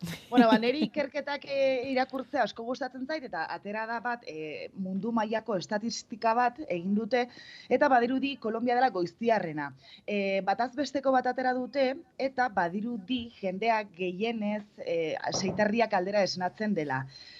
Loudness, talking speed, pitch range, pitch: -30 LUFS, 135 wpm, 200-255 Hz, 230 Hz